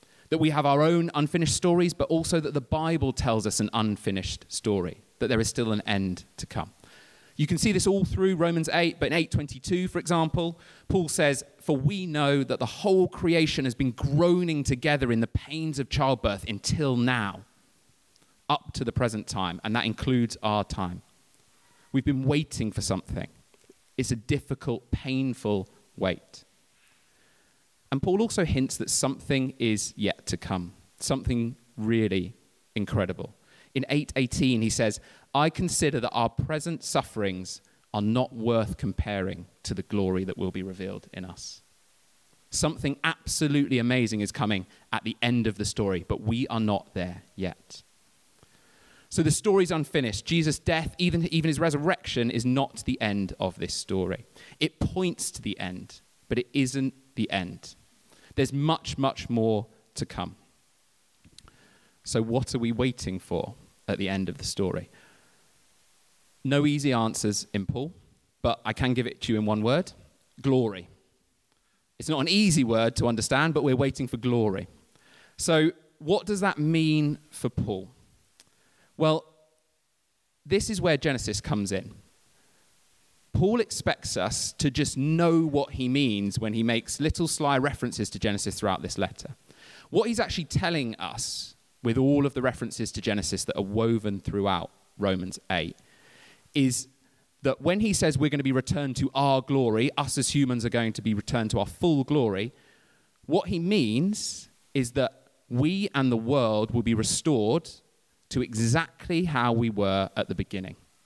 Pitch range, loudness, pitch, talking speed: 105-150 Hz, -27 LUFS, 130 Hz, 165 wpm